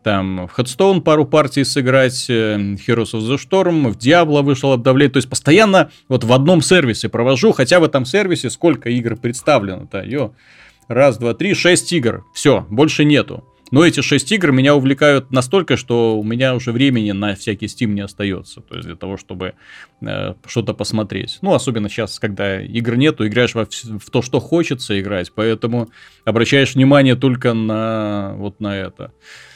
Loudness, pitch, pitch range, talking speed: -15 LUFS, 125 Hz, 110-145 Hz, 170 wpm